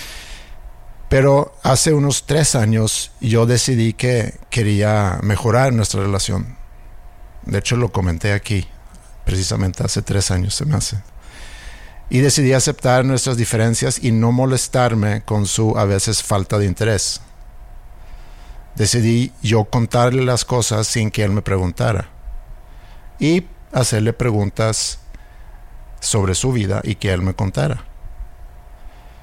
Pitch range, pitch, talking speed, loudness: 100-120 Hz, 110 Hz, 125 wpm, -17 LUFS